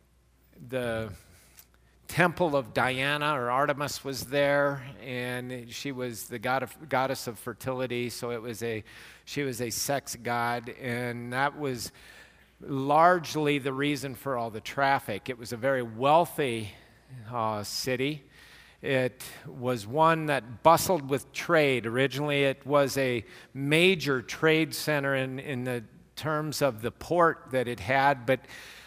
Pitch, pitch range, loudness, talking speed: 130 Hz, 120-145 Hz, -28 LUFS, 140 wpm